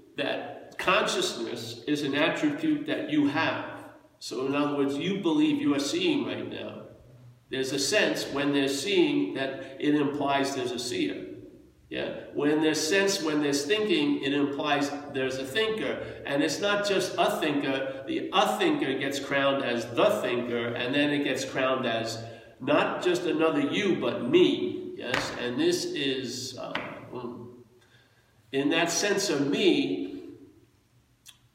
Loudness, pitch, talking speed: -27 LUFS, 145 Hz, 150 wpm